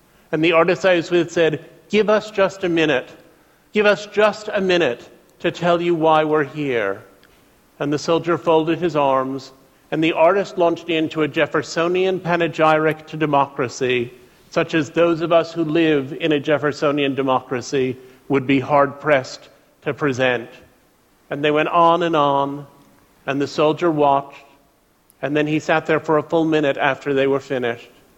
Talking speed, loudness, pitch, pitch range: 170 wpm, -19 LUFS, 155 Hz, 140-170 Hz